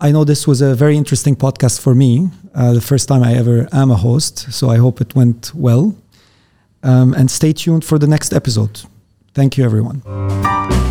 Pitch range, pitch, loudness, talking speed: 115-145 Hz, 130 Hz, -13 LUFS, 200 wpm